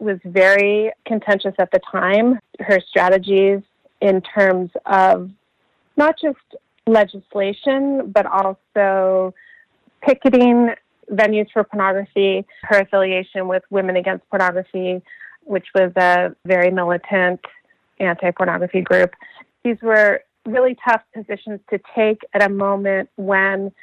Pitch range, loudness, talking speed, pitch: 190-220 Hz, -17 LUFS, 115 wpm, 195 Hz